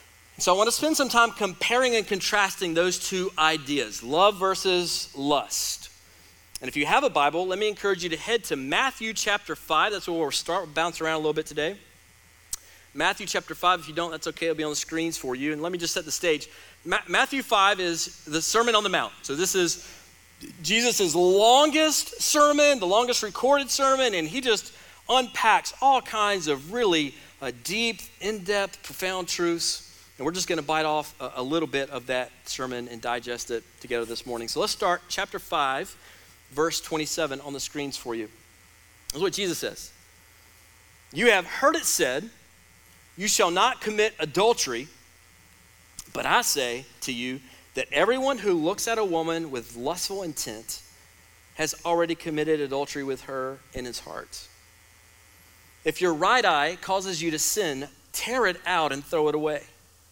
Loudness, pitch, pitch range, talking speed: -25 LUFS, 160 Hz, 120-200 Hz, 180 wpm